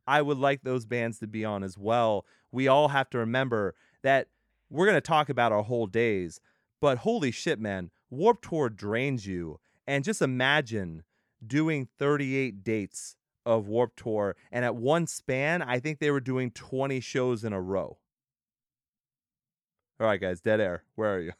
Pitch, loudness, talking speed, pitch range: 120 Hz, -28 LUFS, 175 wpm, 110-140 Hz